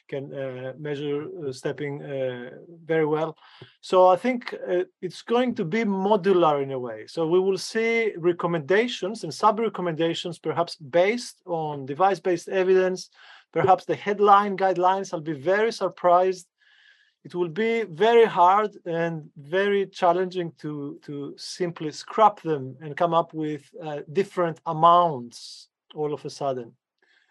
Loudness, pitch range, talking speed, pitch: -24 LUFS, 150-195 Hz, 145 wpm, 175 Hz